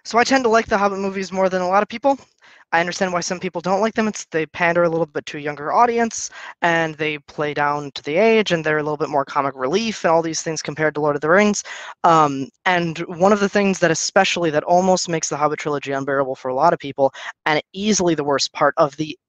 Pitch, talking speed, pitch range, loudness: 170 Hz, 260 wpm, 150-195 Hz, -19 LUFS